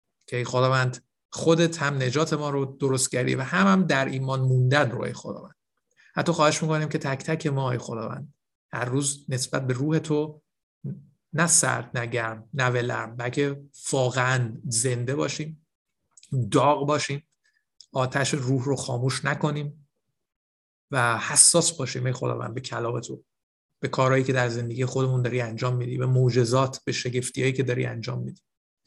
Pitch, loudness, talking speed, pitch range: 135 Hz, -25 LUFS, 160 wpm, 125-150 Hz